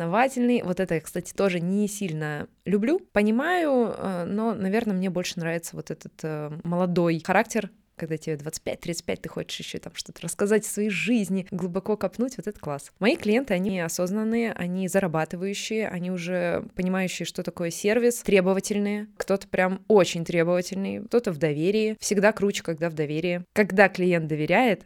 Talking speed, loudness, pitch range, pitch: 150 wpm, -26 LUFS, 175-210 Hz, 190 Hz